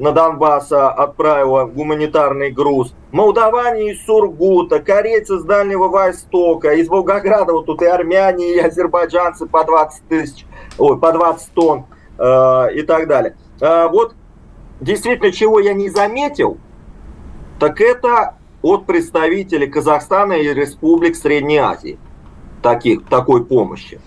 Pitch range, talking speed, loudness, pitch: 150-200 Hz, 125 wpm, -14 LUFS, 165 Hz